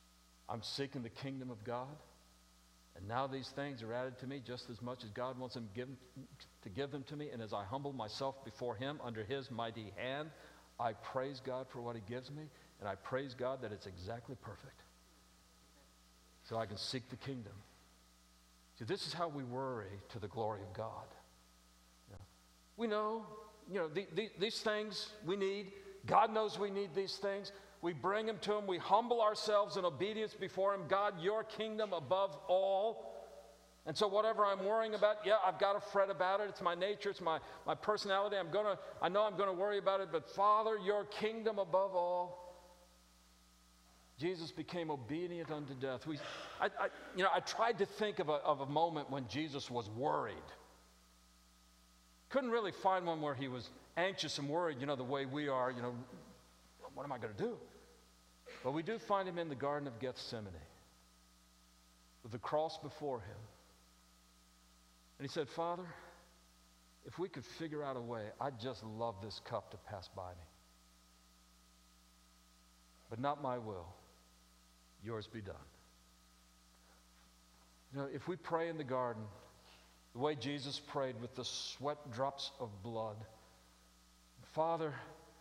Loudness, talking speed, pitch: -40 LUFS, 175 wpm, 130 Hz